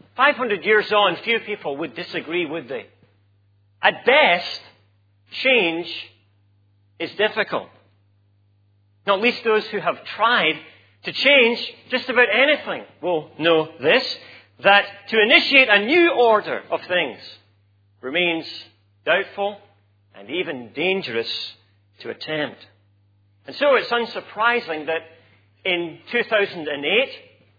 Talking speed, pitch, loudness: 110 wpm, 160 Hz, -19 LUFS